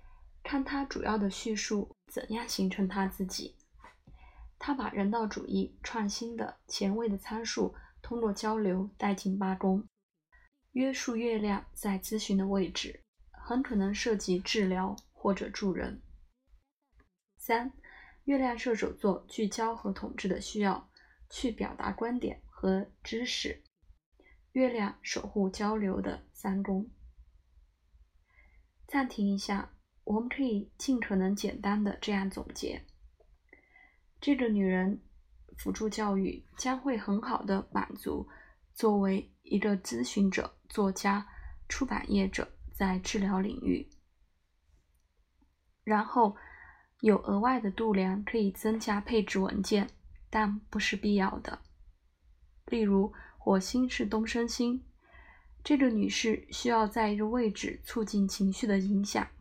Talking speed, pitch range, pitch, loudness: 190 characters per minute, 195-230 Hz, 205 Hz, -32 LUFS